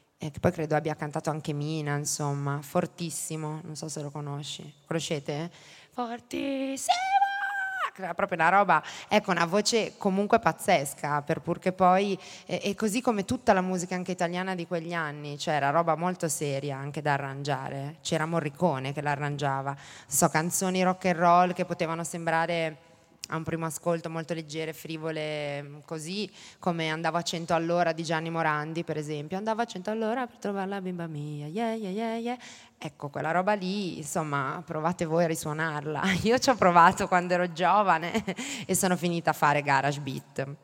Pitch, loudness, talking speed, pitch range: 170 Hz, -28 LUFS, 165 wpm, 155-185 Hz